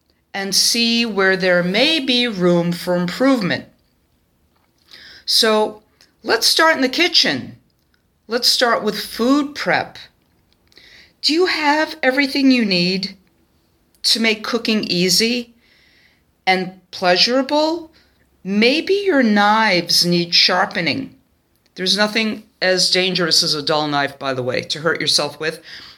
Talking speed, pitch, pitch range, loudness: 120 wpm, 210 Hz, 180-255 Hz, -16 LUFS